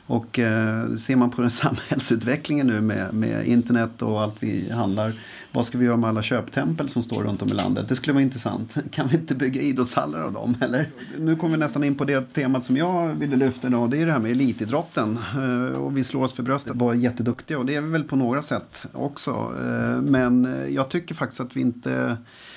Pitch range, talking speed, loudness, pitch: 115-140 Hz, 220 wpm, -24 LUFS, 125 Hz